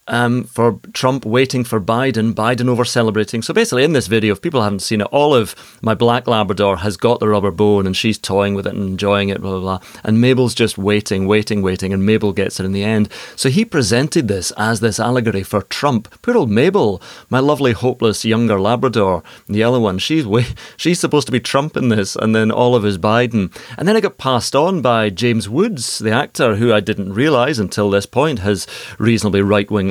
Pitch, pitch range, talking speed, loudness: 110 Hz, 105-125 Hz, 215 wpm, -16 LUFS